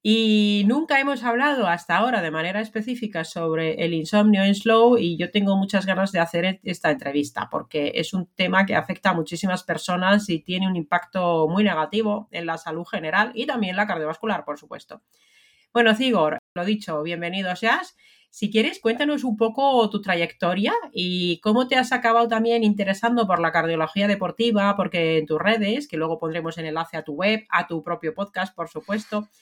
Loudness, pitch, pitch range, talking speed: -22 LUFS, 195 Hz, 170-225 Hz, 180 wpm